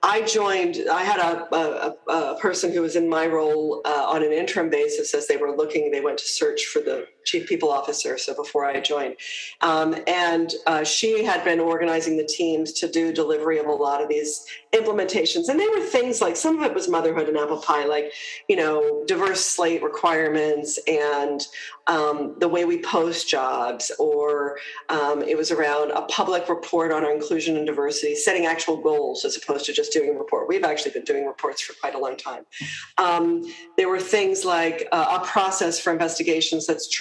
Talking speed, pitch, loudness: 200 wpm, 170 Hz, -23 LUFS